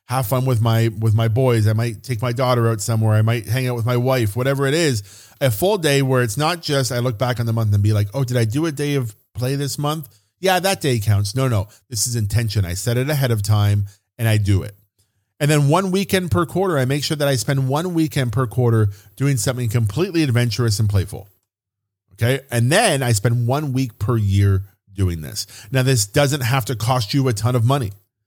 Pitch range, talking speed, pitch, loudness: 110-135 Hz, 240 wpm, 120 Hz, -19 LUFS